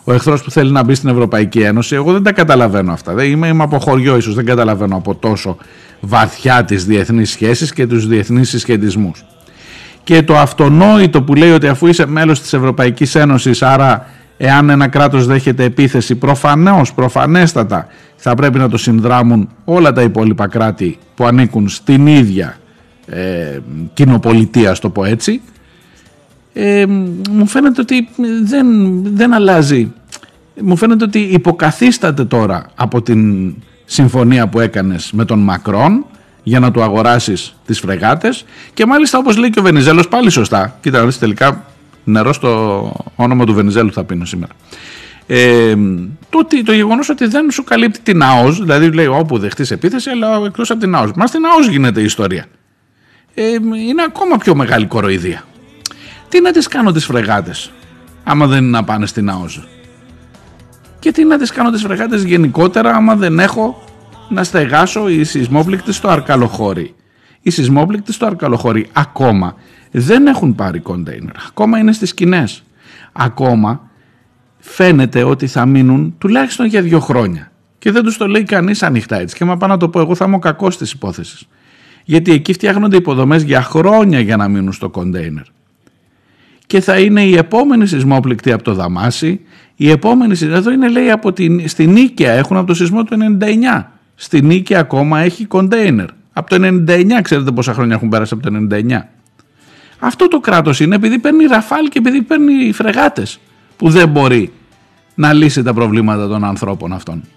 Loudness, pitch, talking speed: -11 LUFS, 145 Hz, 165 wpm